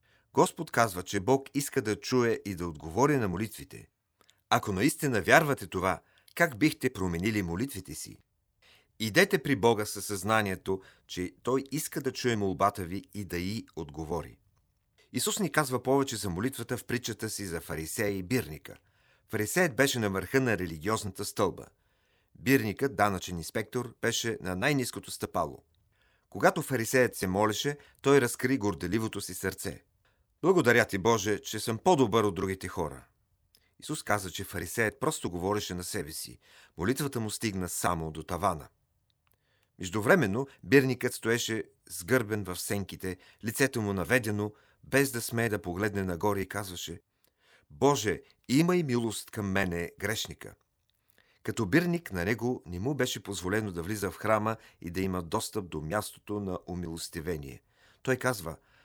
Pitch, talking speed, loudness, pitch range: 105 Hz, 145 wpm, -30 LUFS, 95-125 Hz